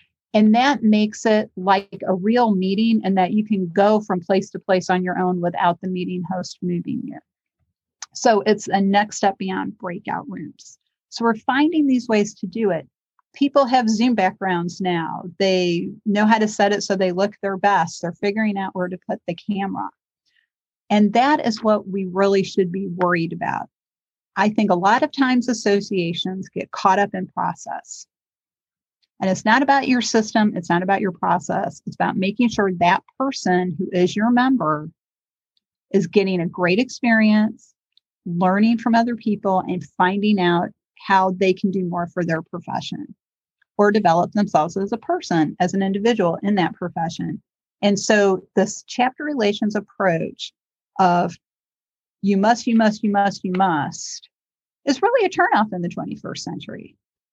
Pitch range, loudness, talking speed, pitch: 185-225 Hz, -20 LUFS, 175 wpm, 200 Hz